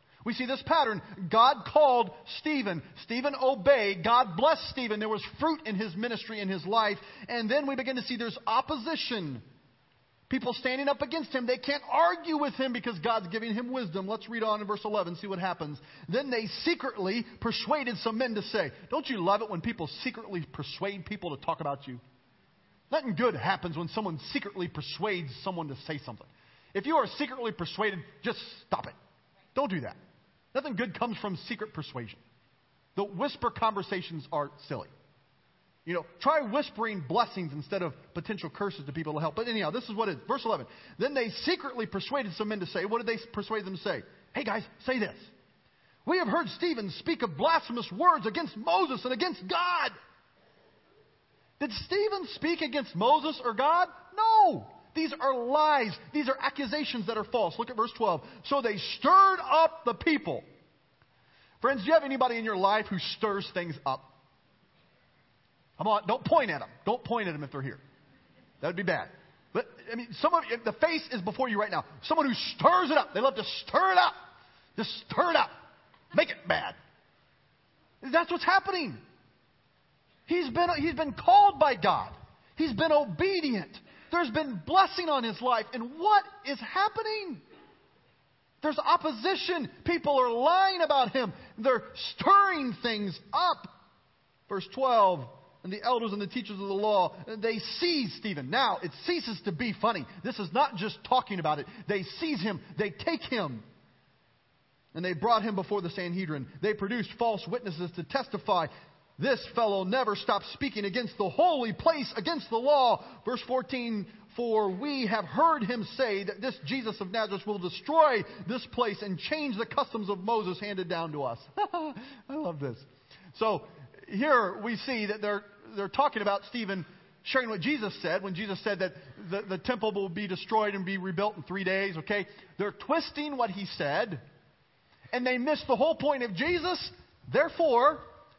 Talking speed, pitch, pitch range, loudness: 180 wpm, 225 Hz, 190-275 Hz, -30 LUFS